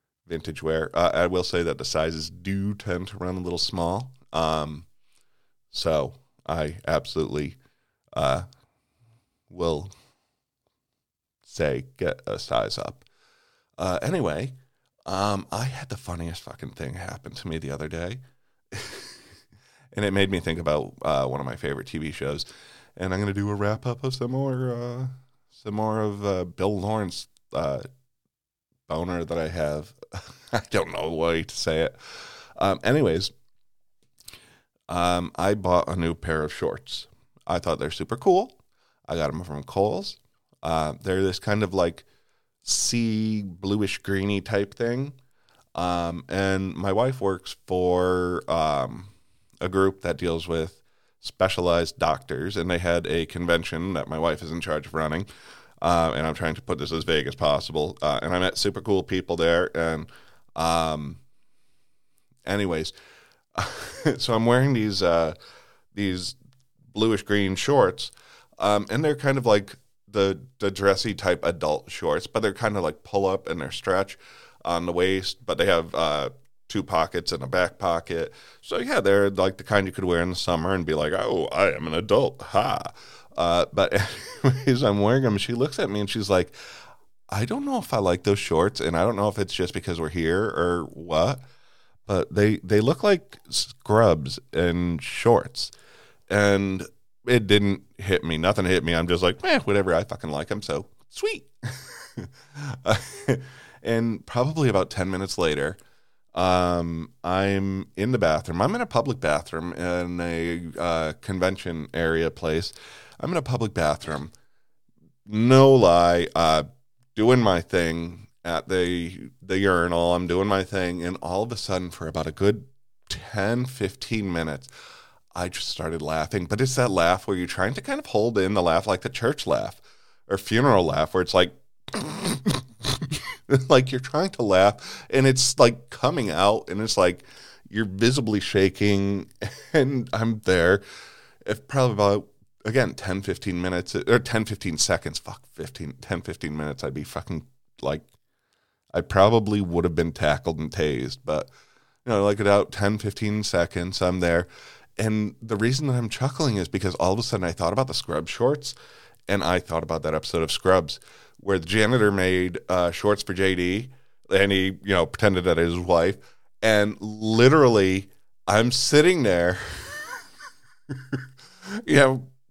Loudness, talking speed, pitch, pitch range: -24 LUFS, 165 wpm, 95 Hz, 85-115 Hz